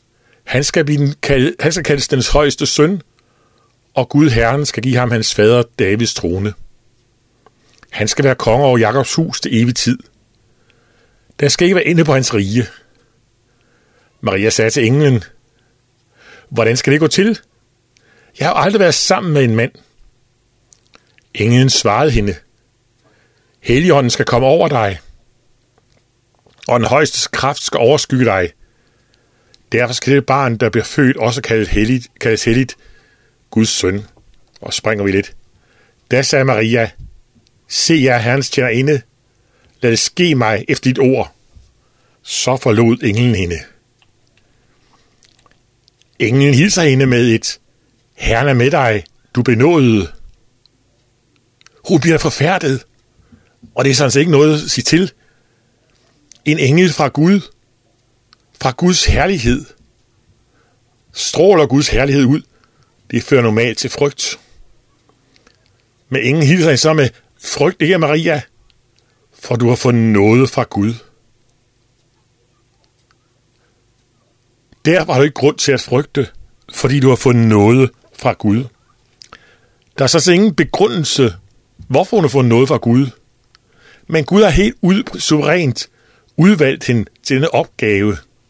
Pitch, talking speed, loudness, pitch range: 120 Hz, 135 wpm, -13 LUFS, 115-140 Hz